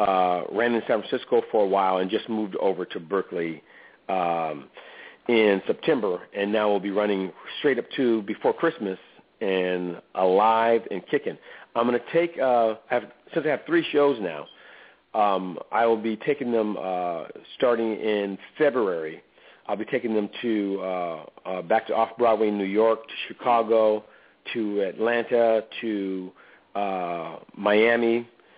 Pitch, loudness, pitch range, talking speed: 110 Hz, -25 LUFS, 100-115 Hz, 155 wpm